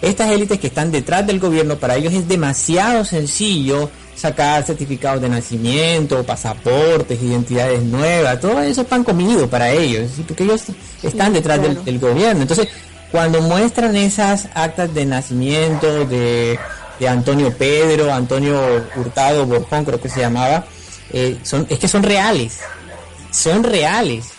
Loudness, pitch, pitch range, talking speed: -16 LUFS, 145 Hz, 125-170 Hz, 145 wpm